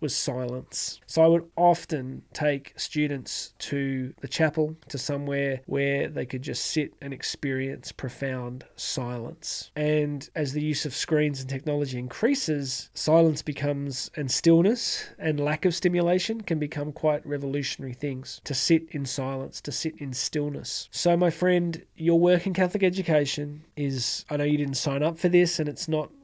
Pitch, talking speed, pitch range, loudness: 150 Hz, 165 wpm, 135-160 Hz, -27 LUFS